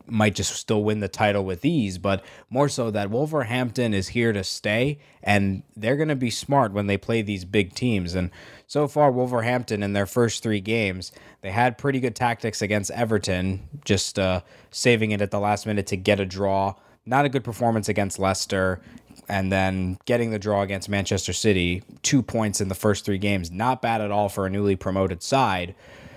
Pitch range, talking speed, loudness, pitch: 100-120 Hz, 200 wpm, -24 LUFS, 105 Hz